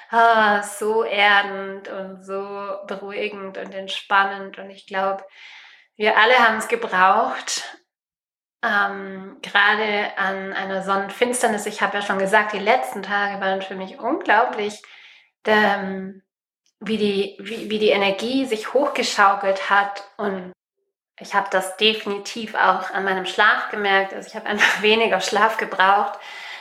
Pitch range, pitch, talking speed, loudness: 195-215 Hz, 200 Hz, 135 wpm, -20 LUFS